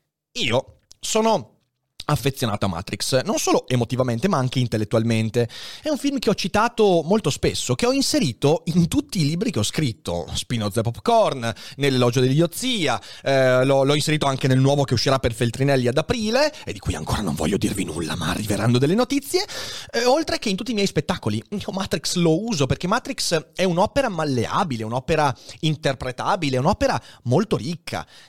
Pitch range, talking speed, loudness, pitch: 125-205 Hz, 170 wpm, -22 LUFS, 140 Hz